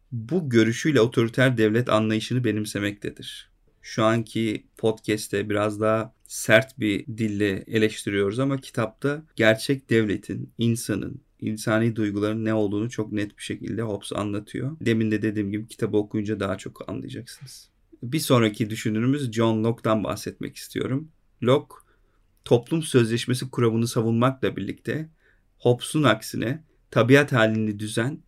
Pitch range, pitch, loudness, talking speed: 105-125 Hz, 110 Hz, -24 LUFS, 120 wpm